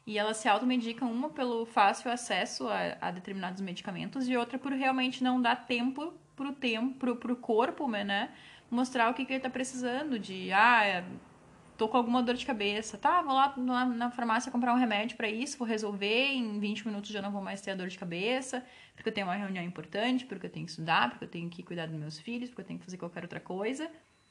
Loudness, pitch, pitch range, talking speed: -32 LUFS, 235 Hz, 200-255 Hz, 230 wpm